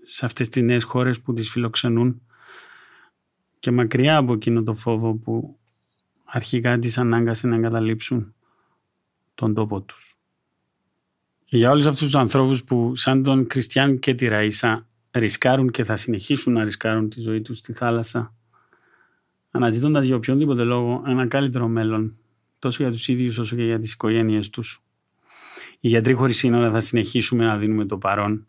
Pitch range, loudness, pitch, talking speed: 115-125 Hz, -21 LUFS, 120 Hz, 155 wpm